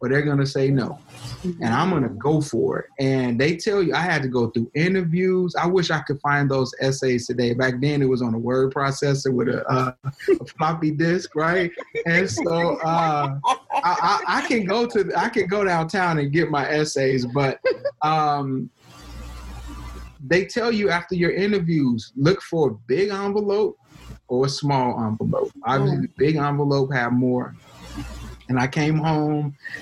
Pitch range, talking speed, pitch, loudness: 130-180 Hz, 175 wpm, 145 Hz, -22 LUFS